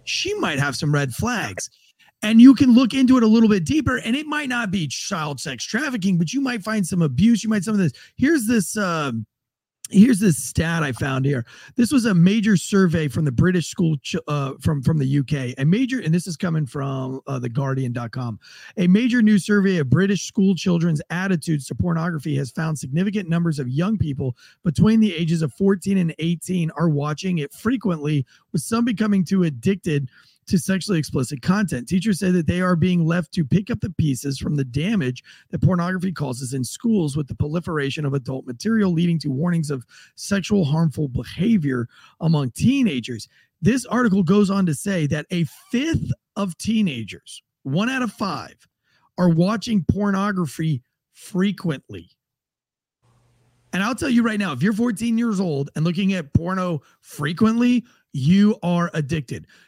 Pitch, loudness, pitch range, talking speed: 175 Hz, -21 LUFS, 145-205 Hz, 180 wpm